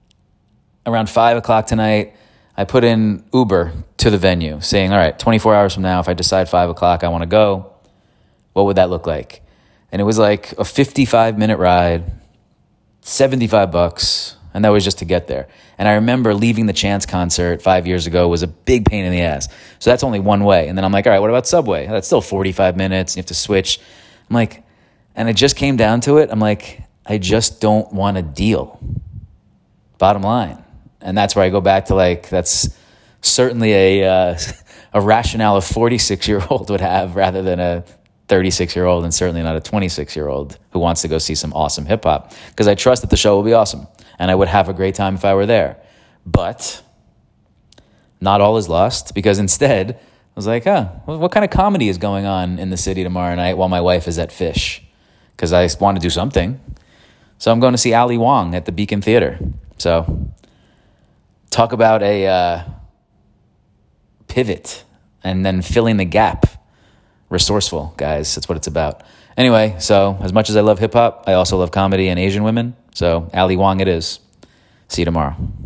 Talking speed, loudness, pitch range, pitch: 205 wpm, -16 LUFS, 90-110 Hz, 95 Hz